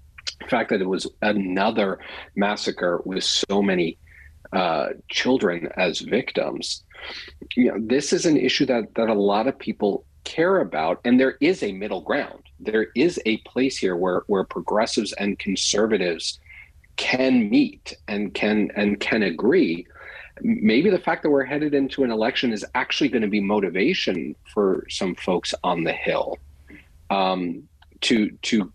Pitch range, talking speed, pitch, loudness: 90-130 Hz, 155 wpm, 105 Hz, -22 LUFS